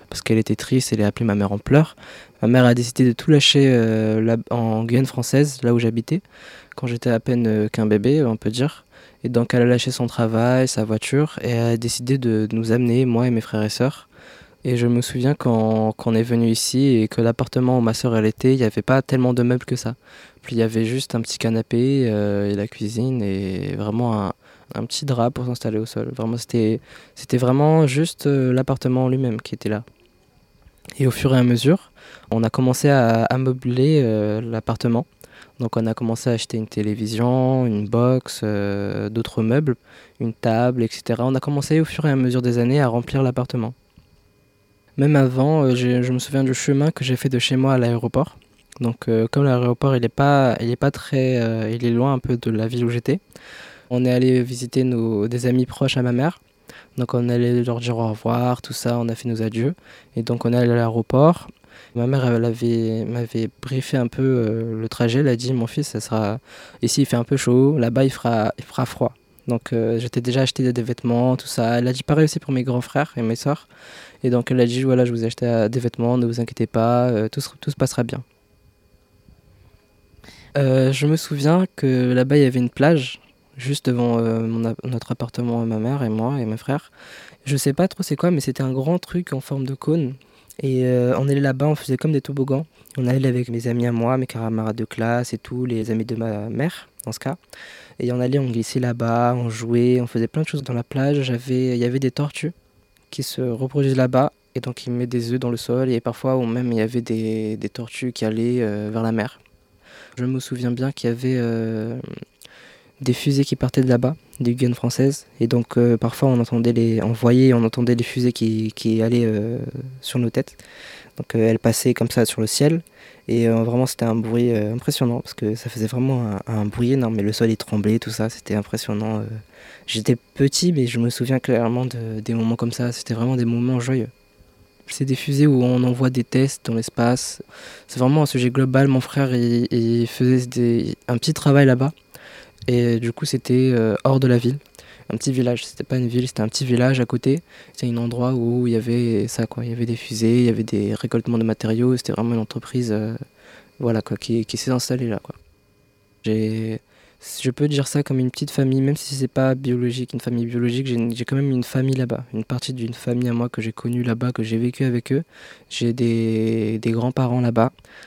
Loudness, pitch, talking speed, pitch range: -20 LUFS, 120 Hz, 230 wpm, 115-130 Hz